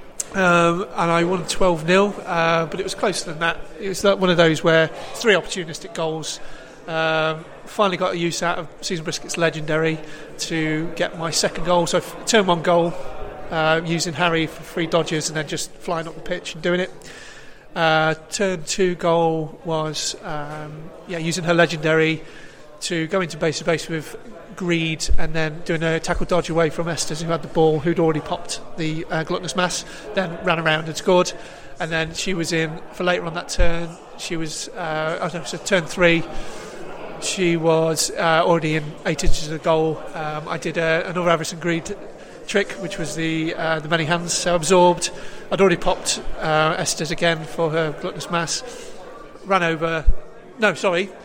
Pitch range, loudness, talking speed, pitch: 160-175 Hz, -21 LUFS, 185 wpm, 165 Hz